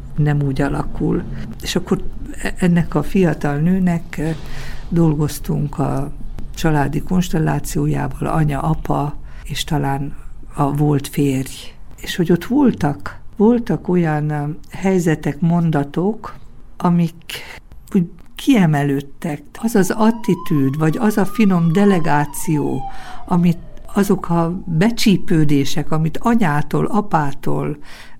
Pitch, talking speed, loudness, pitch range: 160 Hz, 100 wpm, -18 LUFS, 145-180 Hz